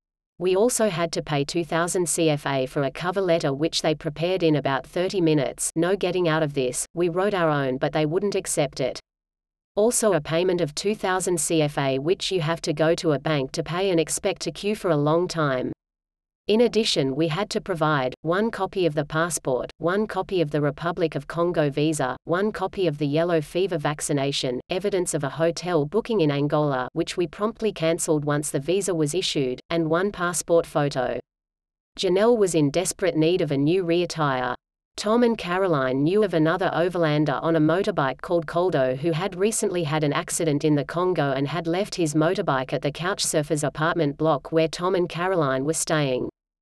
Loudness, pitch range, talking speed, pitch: -23 LUFS, 150-180 Hz, 195 wpm, 165 Hz